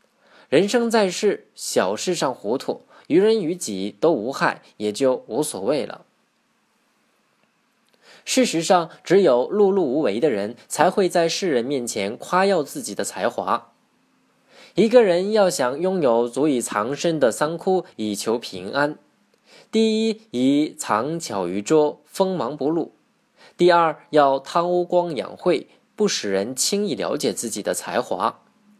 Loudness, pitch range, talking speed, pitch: -21 LUFS, 140-210 Hz, 200 characters per minute, 175 Hz